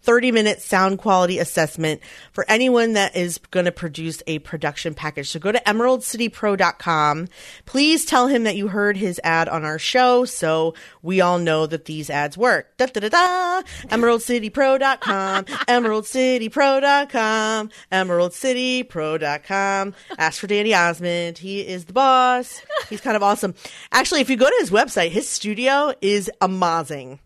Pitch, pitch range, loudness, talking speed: 205 Hz, 170-250 Hz, -19 LUFS, 150 wpm